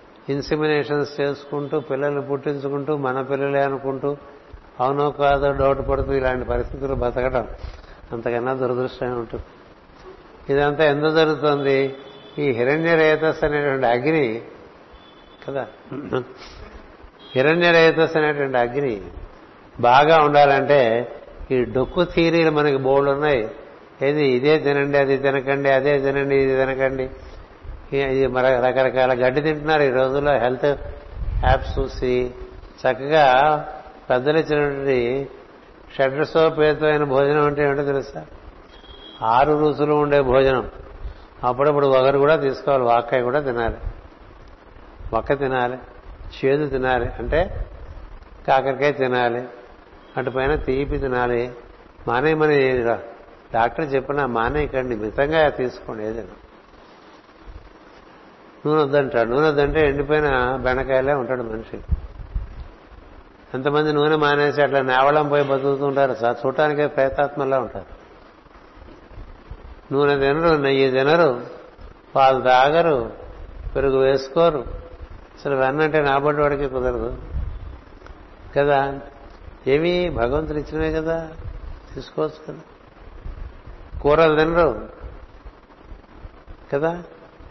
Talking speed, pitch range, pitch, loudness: 90 wpm, 125-145 Hz, 135 Hz, -20 LUFS